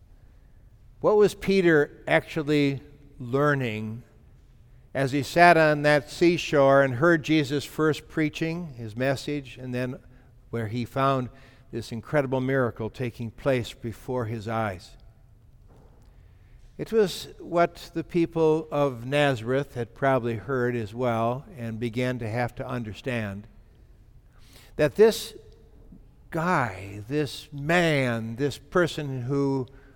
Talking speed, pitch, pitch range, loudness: 115 wpm, 135 Hz, 115-150 Hz, -25 LUFS